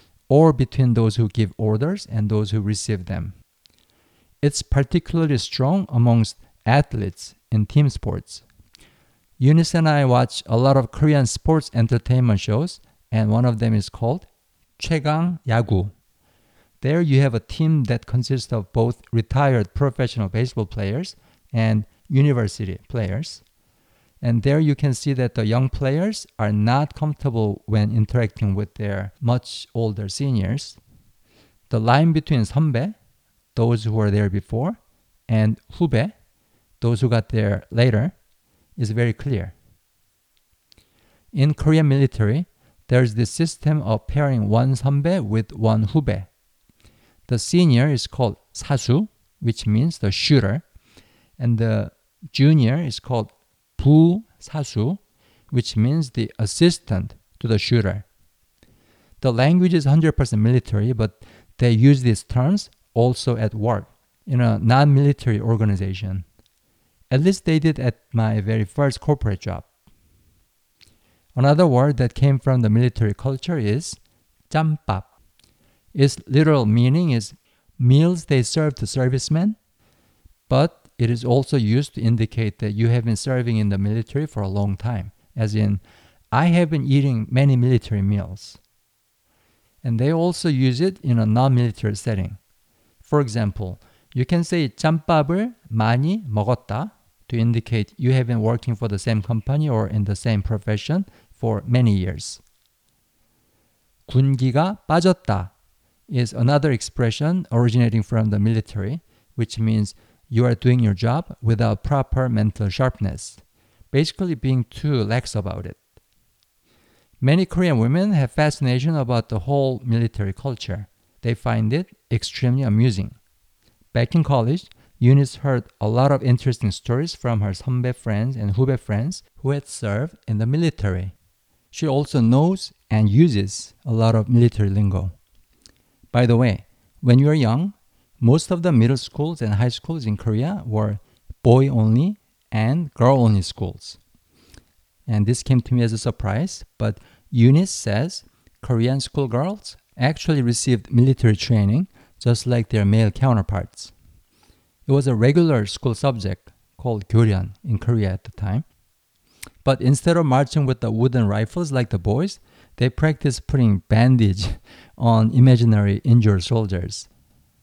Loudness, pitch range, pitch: -20 LUFS, 105-140 Hz, 120 Hz